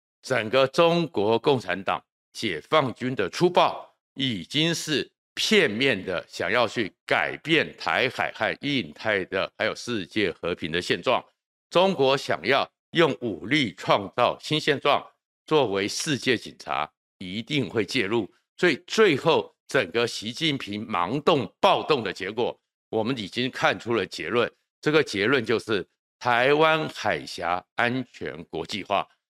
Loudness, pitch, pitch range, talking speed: -25 LUFS, 135 Hz, 115-155 Hz, 205 characters per minute